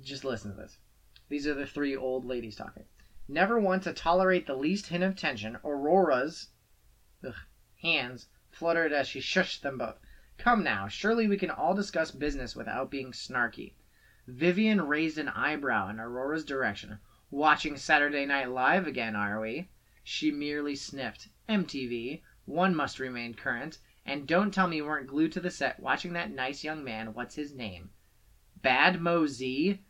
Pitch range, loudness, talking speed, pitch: 125-170 Hz, -30 LUFS, 165 wpm, 145 Hz